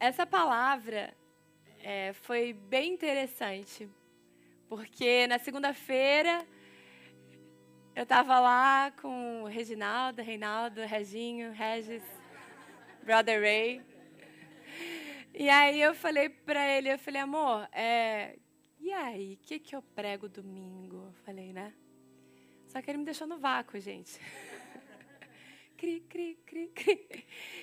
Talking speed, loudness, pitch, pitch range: 115 wpm, -30 LUFS, 235 Hz, 200-280 Hz